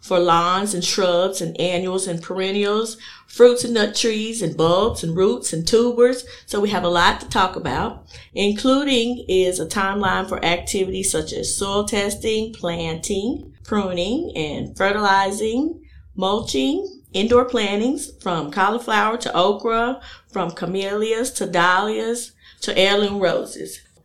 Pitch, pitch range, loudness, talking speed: 200 Hz, 180-225 Hz, -20 LUFS, 135 wpm